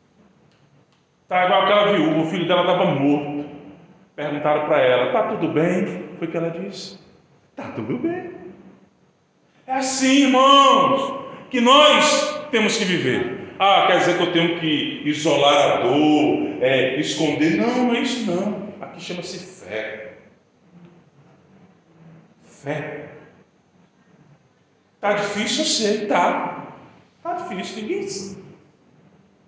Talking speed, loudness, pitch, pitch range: 120 wpm, -19 LUFS, 180 Hz, 155-240 Hz